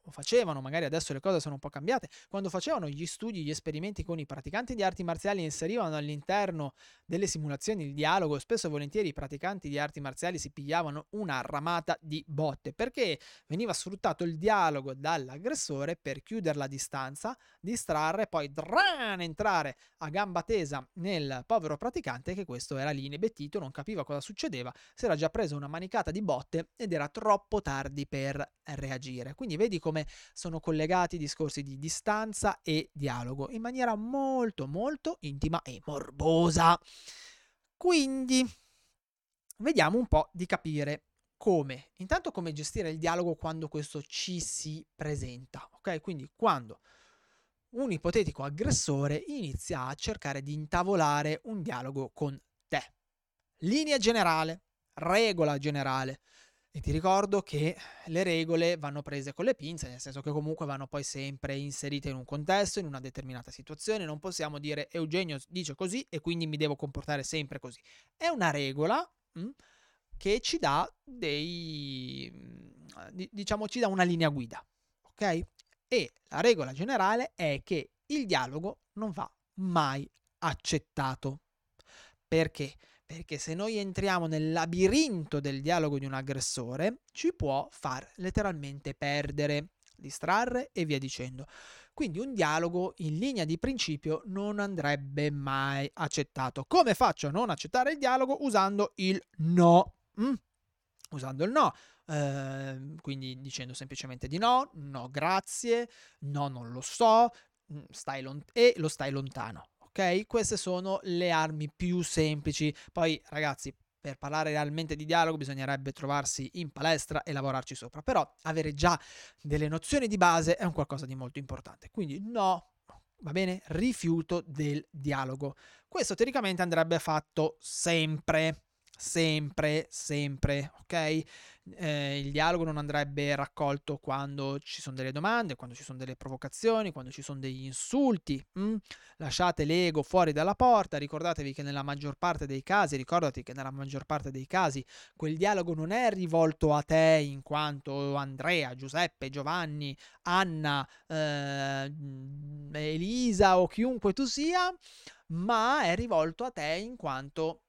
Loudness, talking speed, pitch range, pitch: -32 LUFS, 145 wpm, 140-190 Hz, 155 Hz